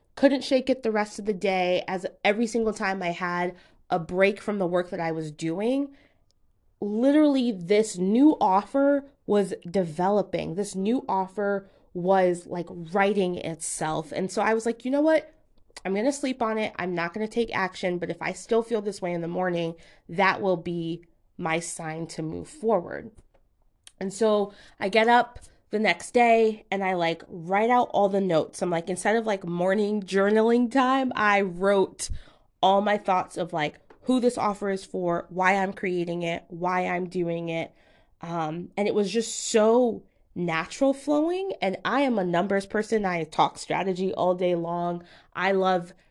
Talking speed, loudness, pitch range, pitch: 180 wpm, -25 LUFS, 175-220 Hz, 195 Hz